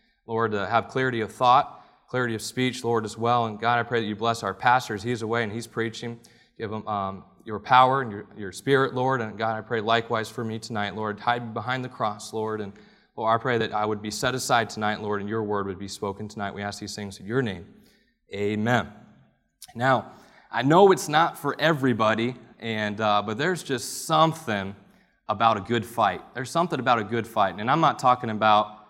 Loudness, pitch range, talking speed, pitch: -25 LUFS, 105-125 Hz, 220 wpm, 115 Hz